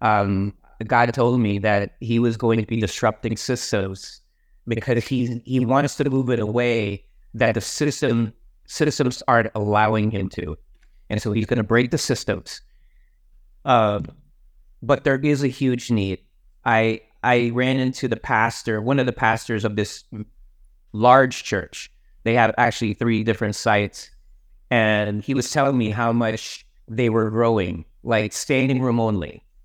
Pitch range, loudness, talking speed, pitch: 105-125 Hz, -21 LUFS, 160 wpm, 115 Hz